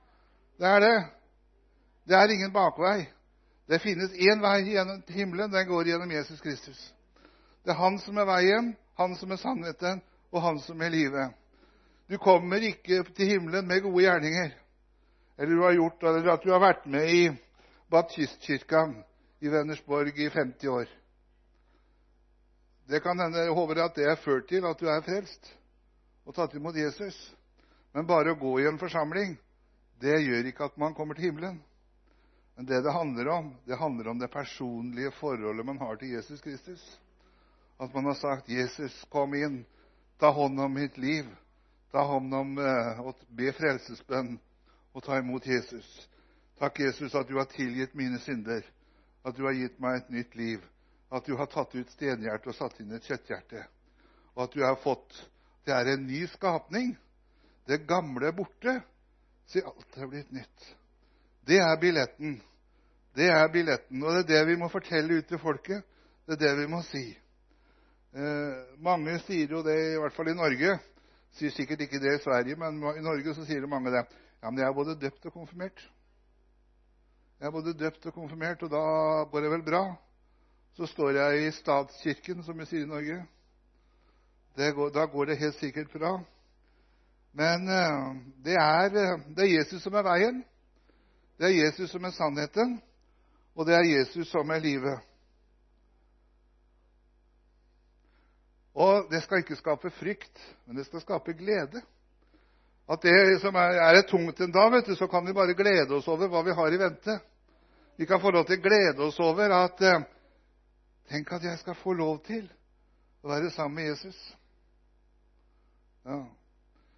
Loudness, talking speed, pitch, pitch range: -28 LUFS, 175 wpm, 150 Hz, 130-175 Hz